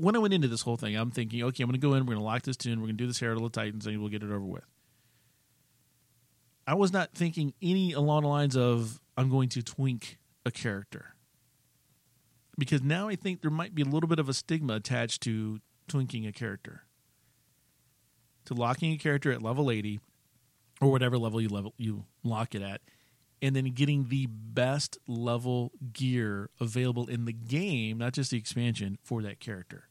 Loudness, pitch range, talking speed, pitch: -31 LUFS, 115-140 Hz, 205 wpm, 125 Hz